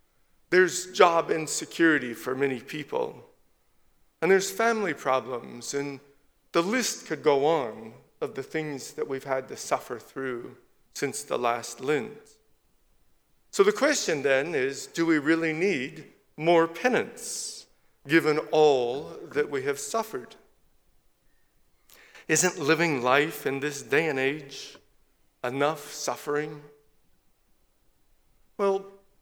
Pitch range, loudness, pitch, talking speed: 135-195 Hz, -27 LUFS, 155 Hz, 115 wpm